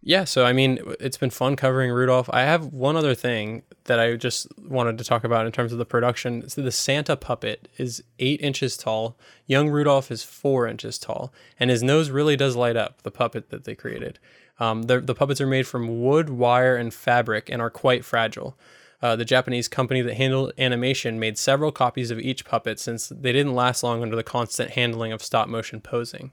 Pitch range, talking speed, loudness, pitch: 115-135 Hz, 210 wpm, -23 LUFS, 125 Hz